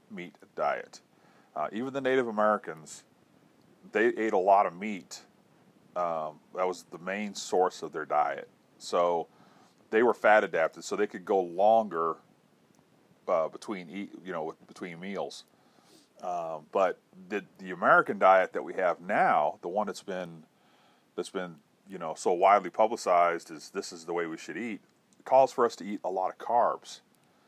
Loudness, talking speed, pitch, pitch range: -29 LUFS, 170 wpm, 95 Hz, 85-105 Hz